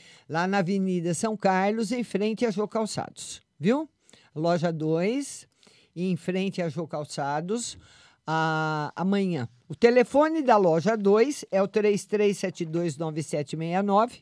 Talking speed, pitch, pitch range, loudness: 115 wpm, 190 Hz, 165-215 Hz, -26 LUFS